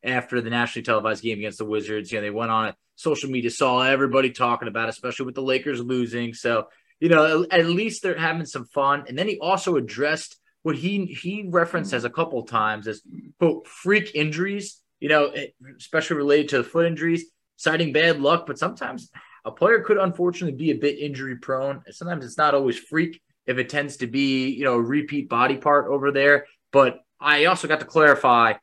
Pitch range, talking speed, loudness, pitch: 125-165 Hz, 210 wpm, -22 LUFS, 145 Hz